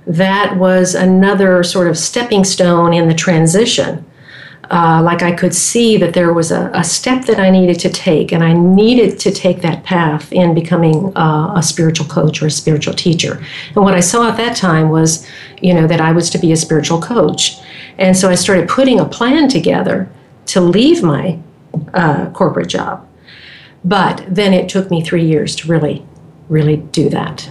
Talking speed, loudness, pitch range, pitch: 190 wpm, -12 LUFS, 160-190 Hz, 175 Hz